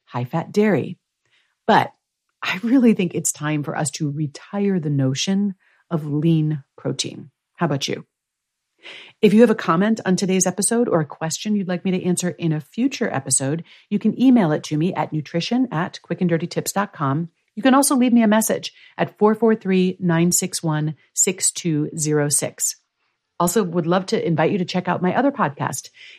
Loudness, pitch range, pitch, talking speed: -20 LUFS, 155-210 Hz, 180 Hz, 170 wpm